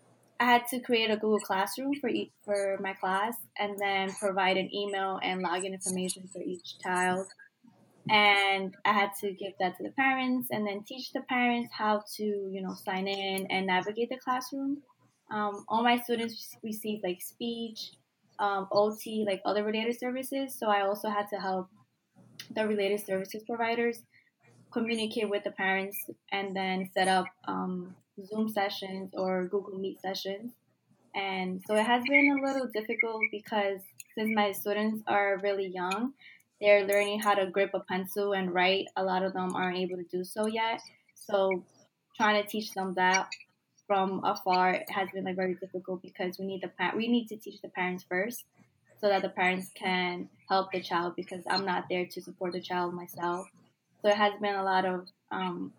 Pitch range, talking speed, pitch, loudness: 185-215 Hz, 180 wpm, 200 Hz, -30 LUFS